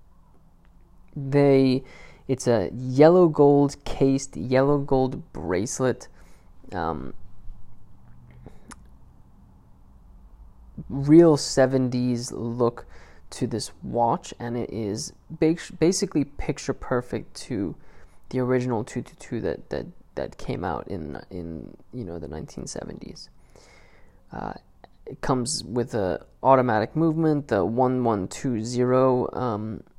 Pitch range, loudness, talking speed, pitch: 100-135 Hz, -24 LUFS, 95 wpm, 125 Hz